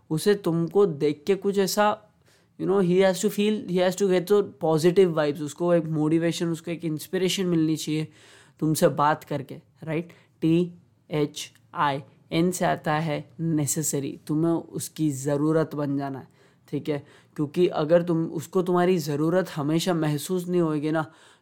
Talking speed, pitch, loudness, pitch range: 165 wpm, 160 Hz, -25 LUFS, 150-180 Hz